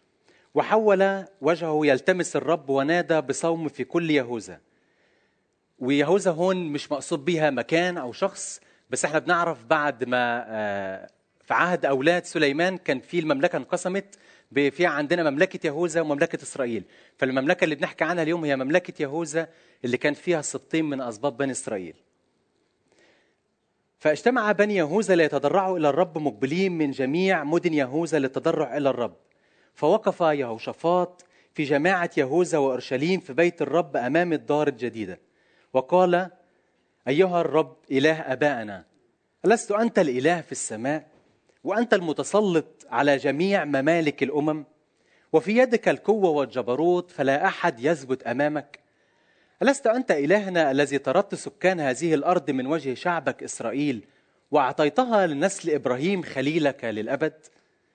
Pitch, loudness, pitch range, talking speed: 160 Hz, -24 LUFS, 140-180 Hz, 125 wpm